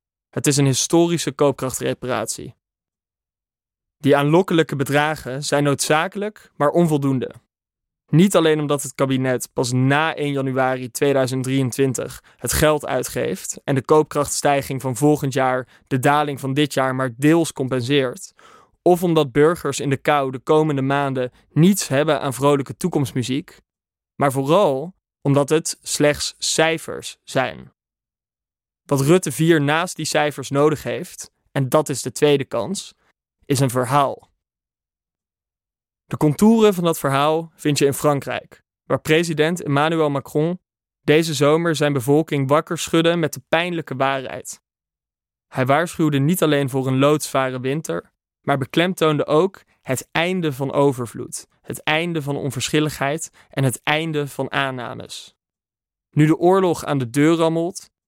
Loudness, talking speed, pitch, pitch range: -19 LUFS, 135 wpm, 145 Hz, 135-155 Hz